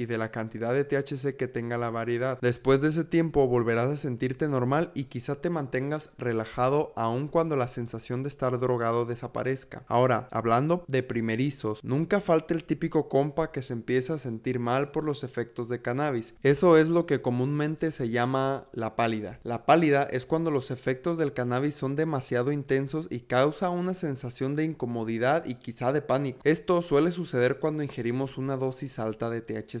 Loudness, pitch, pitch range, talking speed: -28 LUFS, 130 Hz, 120-150 Hz, 185 wpm